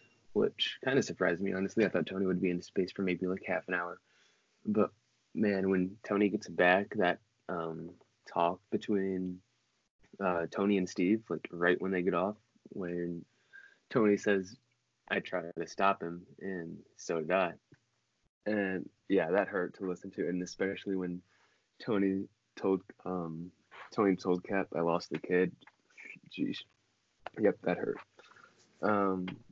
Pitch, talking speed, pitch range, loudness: 95 Hz, 155 wpm, 90-100 Hz, -33 LUFS